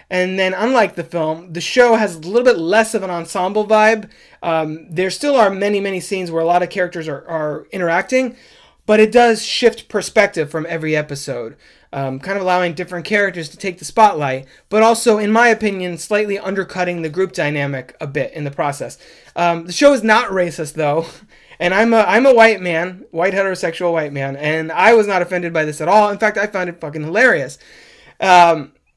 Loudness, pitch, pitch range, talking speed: -16 LUFS, 180 Hz, 165-215 Hz, 205 wpm